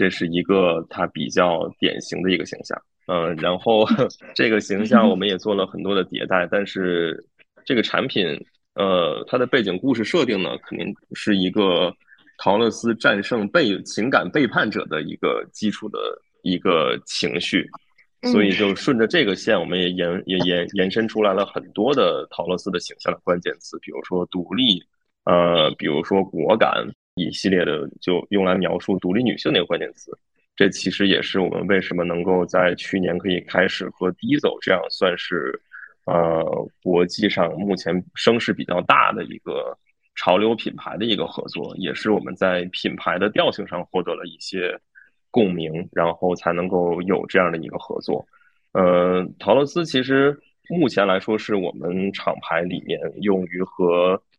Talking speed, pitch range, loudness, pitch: 260 characters per minute, 90-100 Hz, -21 LUFS, 95 Hz